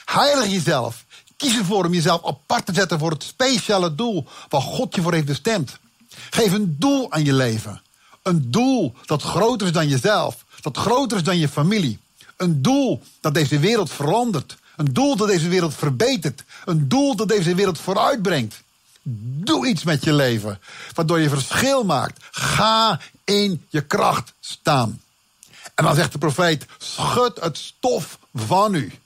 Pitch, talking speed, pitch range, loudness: 175 Hz, 165 wpm, 150-220 Hz, -20 LUFS